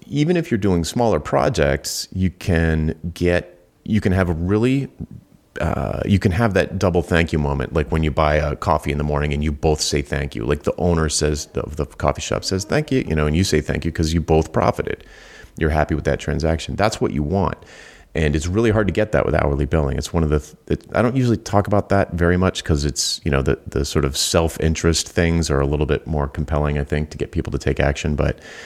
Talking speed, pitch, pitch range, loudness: 250 wpm, 80 Hz, 75-95 Hz, -20 LUFS